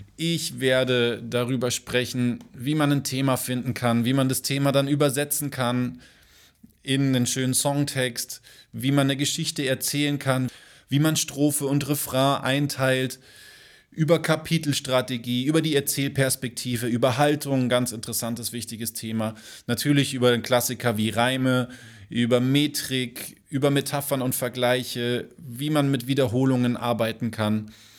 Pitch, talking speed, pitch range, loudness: 130 Hz, 135 wpm, 120-140 Hz, -24 LUFS